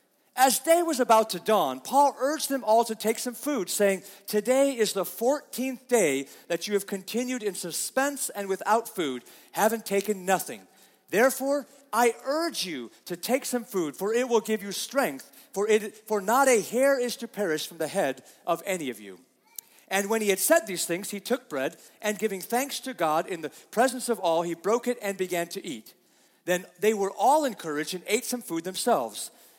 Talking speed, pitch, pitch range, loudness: 200 wpm, 215 Hz, 190-250 Hz, -27 LUFS